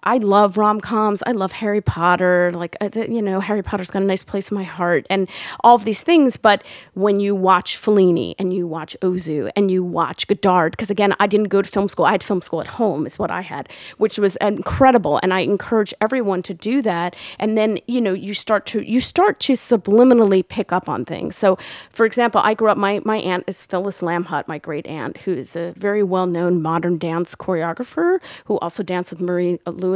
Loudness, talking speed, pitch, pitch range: -19 LUFS, 220 wpm, 195 Hz, 180-215 Hz